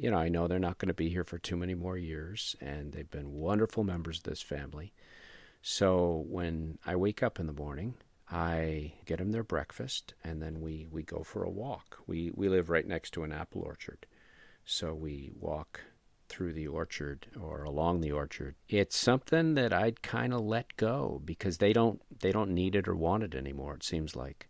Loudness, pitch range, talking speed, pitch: -34 LUFS, 80-95 Hz, 210 wpm, 85 Hz